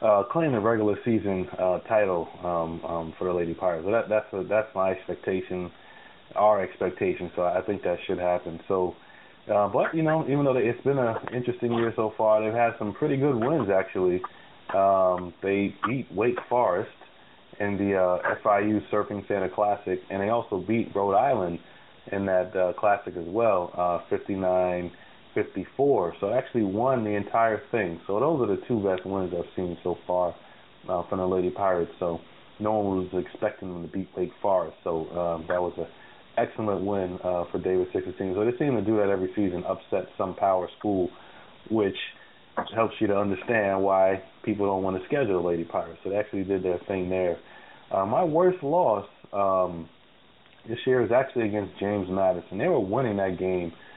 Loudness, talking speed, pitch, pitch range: -26 LUFS, 190 wpm, 95 Hz, 90-105 Hz